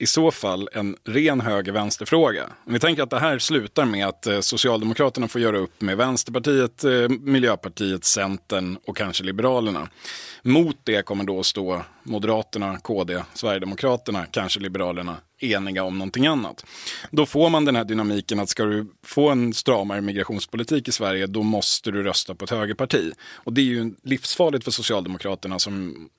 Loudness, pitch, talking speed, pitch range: -22 LUFS, 105 Hz, 165 wpm, 95-125 Hz